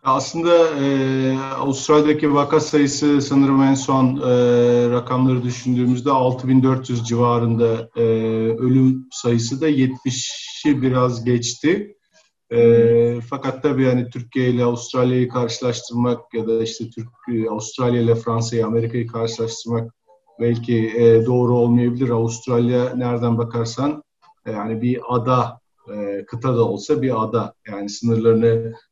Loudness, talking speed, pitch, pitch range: -19 LUFS, 115 wpm, 120 Hz, 115-130 Hz